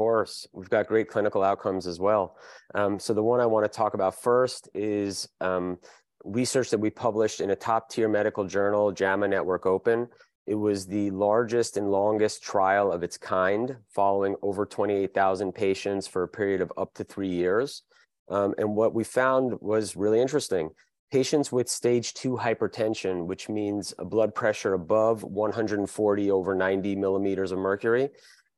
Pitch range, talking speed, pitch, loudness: 95-110 Hz, 165 wpm, 105 Hz, -26 LUFS